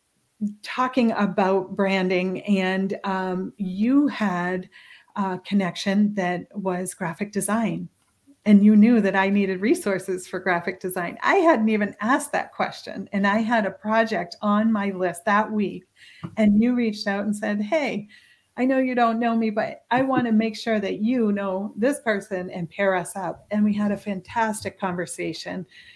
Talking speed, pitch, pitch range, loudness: 170 wpm, 205 Hz, 190-225 Hz, -23 LUFS